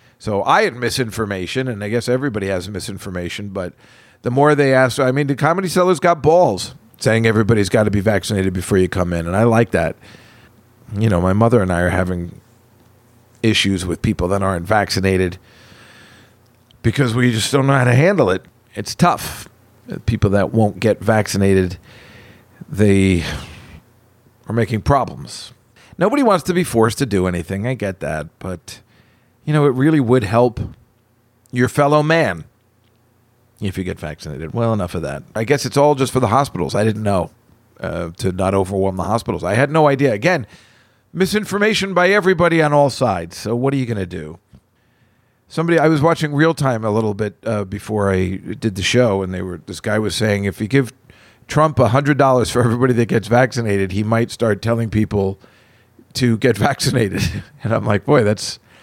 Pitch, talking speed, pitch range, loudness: 115 Hz, 185 wpm, 100-130 Hz, -17 LUFS